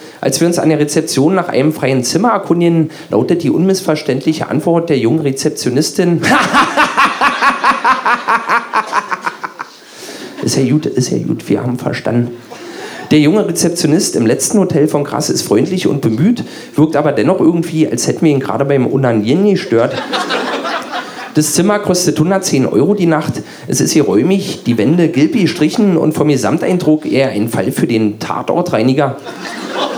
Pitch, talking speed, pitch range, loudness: 155 Hz, 150 wpm, 135-170 Hz, -13 LUFS